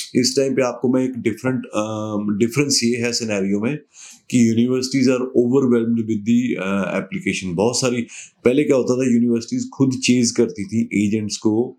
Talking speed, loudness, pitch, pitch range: 170 wpm, -19 LUFS, 120 Hz, 110-130 Hz